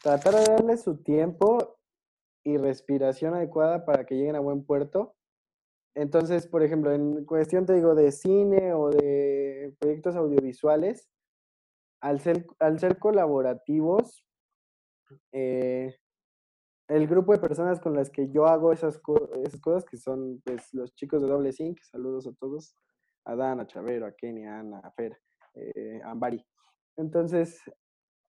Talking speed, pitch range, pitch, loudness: 150 wpm, 130-170 Hz, 150 Hz, -26 LUFS